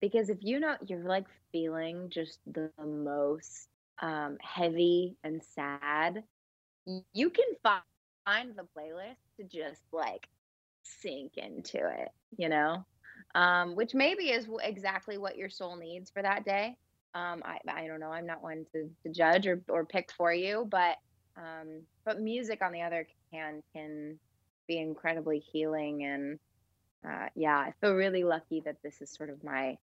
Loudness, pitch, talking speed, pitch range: -33 LUFS, 165 Hz, 160 wpm, 150-190 Hz